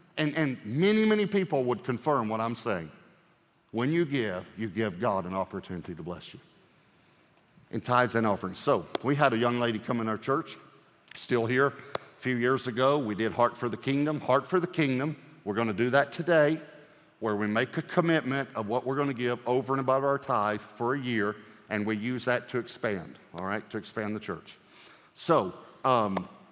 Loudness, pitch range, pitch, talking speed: -29 LUFS, 110-145 Hz, 125 Hz, 205 wpm